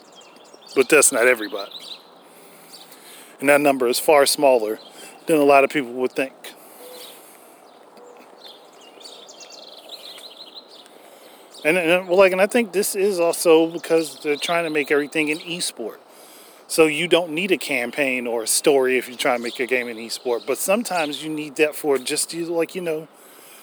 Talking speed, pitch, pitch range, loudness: 160 wpm, 150 Hz, 135-170 Hz, -19 LUFS